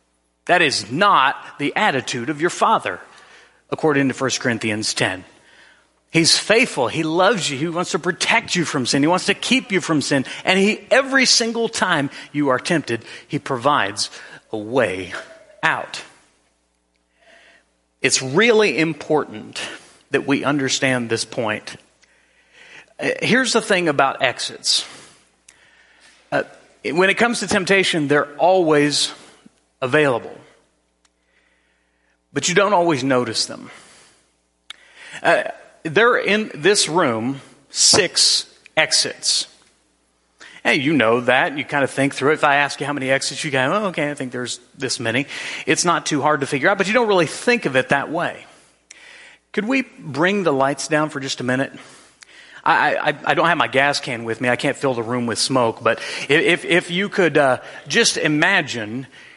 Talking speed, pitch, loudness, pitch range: 160 wpm, 145 Hz, -18 LUFS, 125-180 Hz